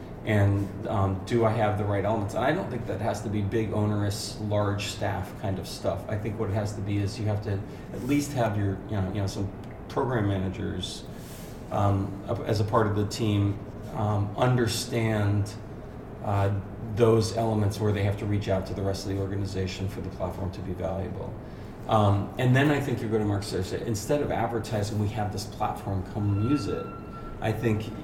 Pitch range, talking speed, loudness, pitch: 100-110 Hz, 205 wpm, -28 LUFS, 105 Hz